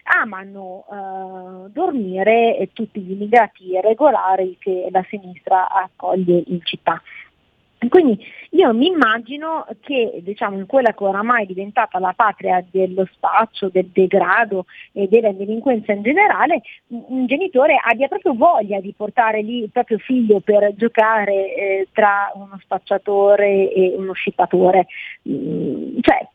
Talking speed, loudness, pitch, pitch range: 130 wpm, -17 LUFS, 205 Hz, 190-235 Hz